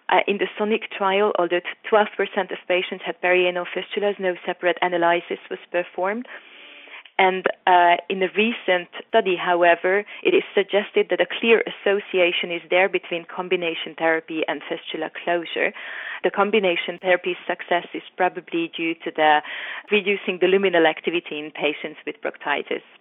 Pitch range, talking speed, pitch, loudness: 175-200 Hz, 145 wpm, 180 Hz, -22 LUFS